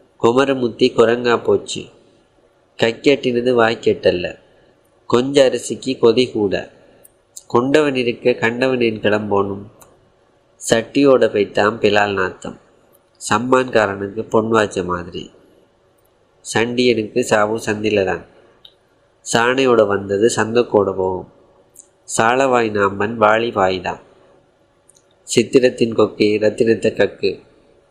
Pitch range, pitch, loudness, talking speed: 105-125 Hz, 115 Hz, -17 LUFS, 85 wpm